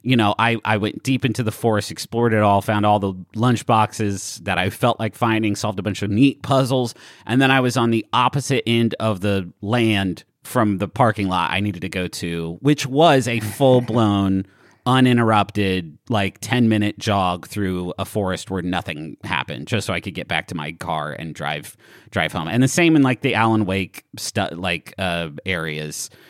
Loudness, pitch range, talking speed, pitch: -20 LUFS, 95-120 Hz, 205 wpm, 105 Hz